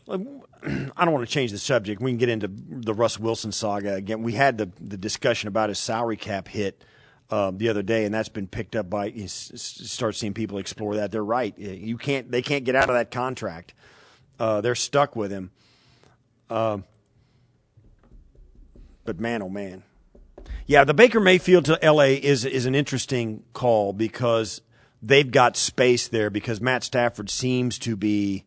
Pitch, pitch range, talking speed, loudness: 115 Hz, 105-130 Hz, 185 wpm, -23 LUFS